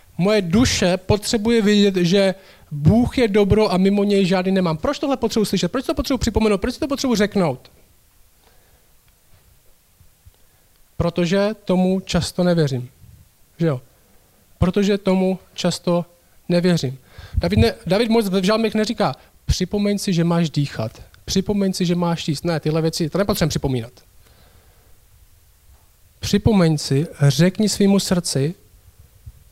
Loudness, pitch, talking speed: -19 LUFS, 175 Hz, 125 wpm